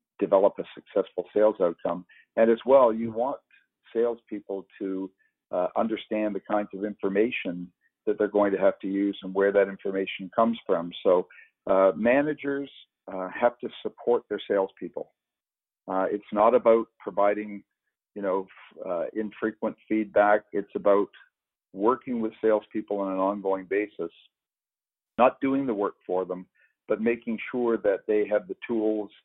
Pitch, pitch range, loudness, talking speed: 105 Hz, 100-115 Hz, -26 LUFS, 150 wpm